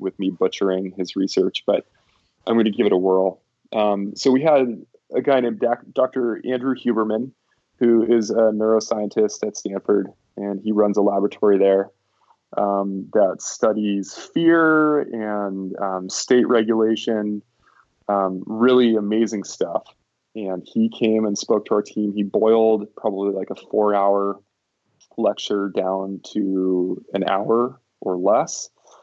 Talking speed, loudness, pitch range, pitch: 145 wpm, -20 LUFS, 100-115 Hz, 105 Hz